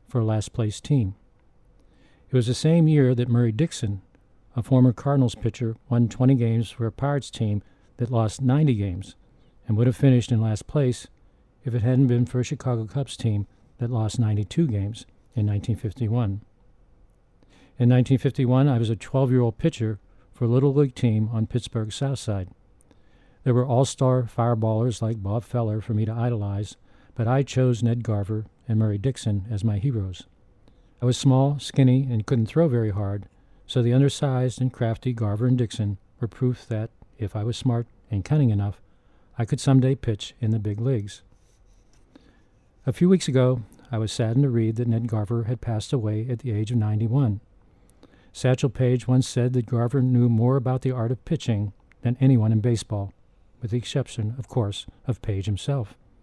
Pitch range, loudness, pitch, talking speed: 105-125 Hz, -24 LUFS, 115 Hz, 180 wpm